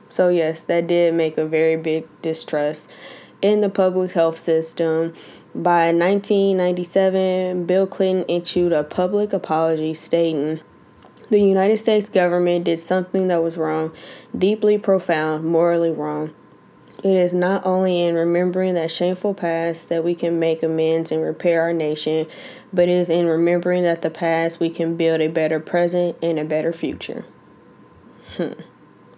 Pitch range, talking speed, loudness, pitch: 160-185 Hz, 150 wpm, -20 LUFS, 170 Hz